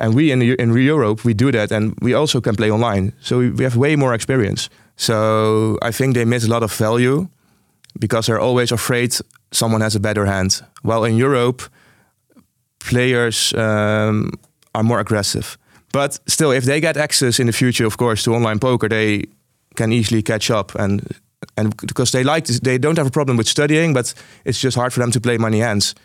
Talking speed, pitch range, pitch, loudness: 205 wpm, 110-130 Hz, 120 Hz, -17 LUFS